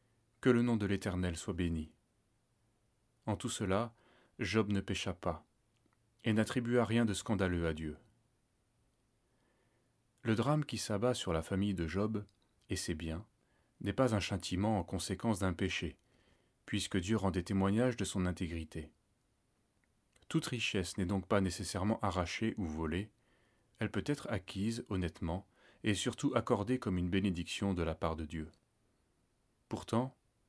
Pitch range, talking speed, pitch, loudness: 95-115 Hz, 150 wpm, 105 Hz, -36 LUFS